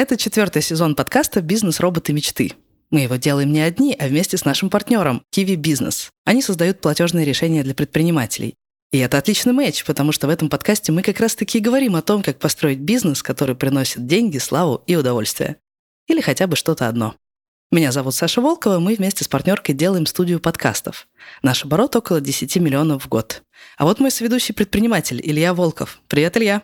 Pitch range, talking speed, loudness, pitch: 145-210 Hz, 185 wpm, -18 LUFS, 165 Hz